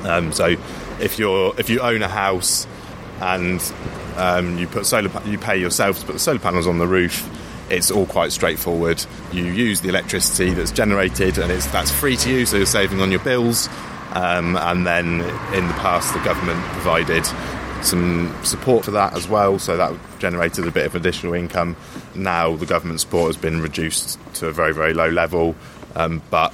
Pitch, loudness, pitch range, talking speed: 90 Hz, -19 LUFS, 85-95 Hz, 190 wpm